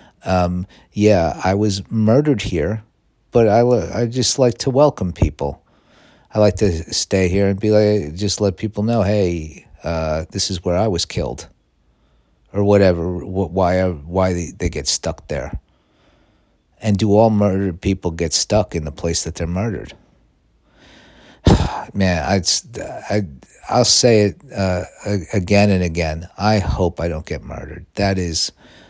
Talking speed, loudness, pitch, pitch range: 160 wpm, -18 LUFS, 95 Hz, 85-105 Hz